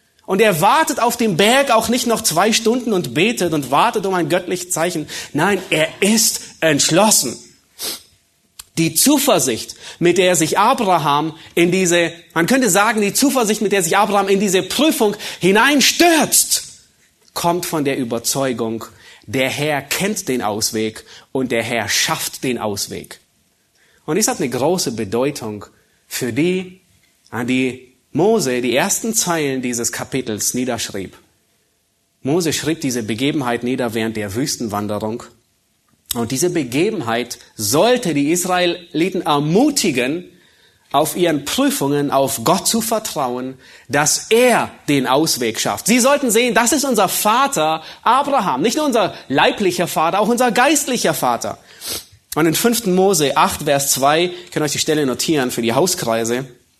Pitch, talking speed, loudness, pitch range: 165 Hz, 145 wpm, -16 LUFS, 130-215 Hz